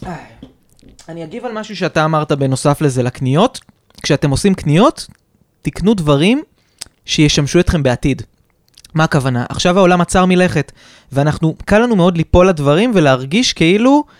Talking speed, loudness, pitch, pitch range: 130 wpm, -13 LUFS, 165 Hz, 145-190 Hz